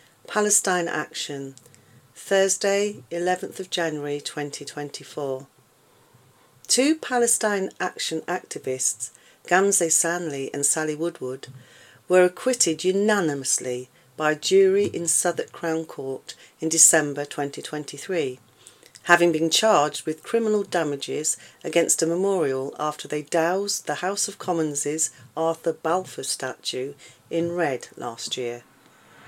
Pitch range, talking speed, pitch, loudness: 140-180 Hz, 105 wpm, 160 Hz, -23 LUFS